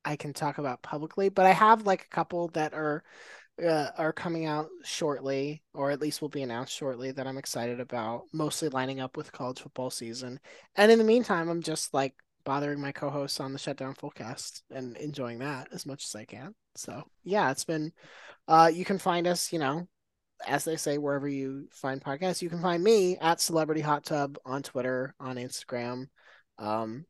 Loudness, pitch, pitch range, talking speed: -29 LUFS, 145 Hz, 130-165 Hz, 195 wpm